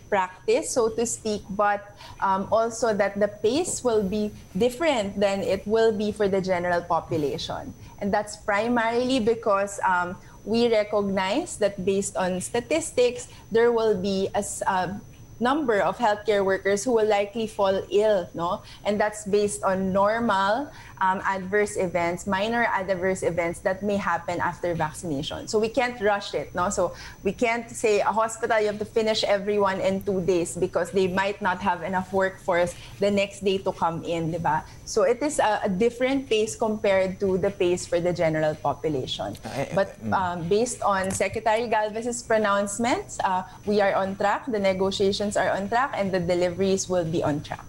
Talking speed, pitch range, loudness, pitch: 170 wpm, 185-220 Hz, -25 LUFS, 200 Hz